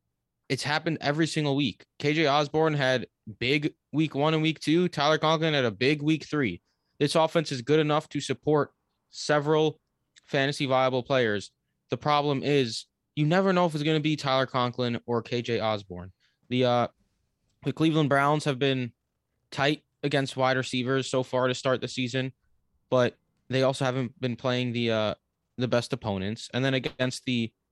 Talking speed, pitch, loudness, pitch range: 175 wpm, 130 Hz, -27 LUFS, 120-150 Hz